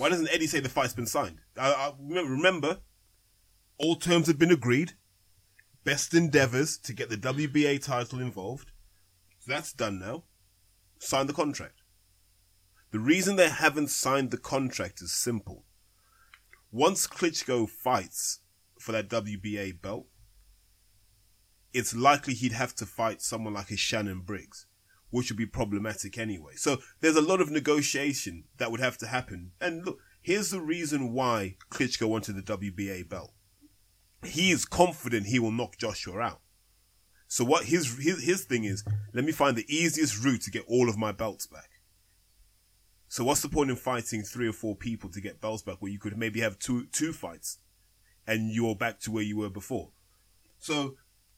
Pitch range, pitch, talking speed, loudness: 95-135 Hz, 110 Hz, 170 wpm, -29 LUFS